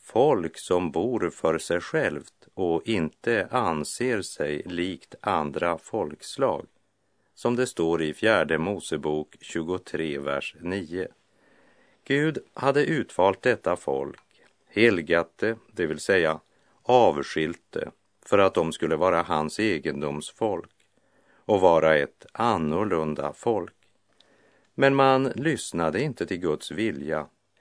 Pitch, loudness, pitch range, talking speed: 85 Hz, -26 LUFS, 75-120 Hz, 110 wpm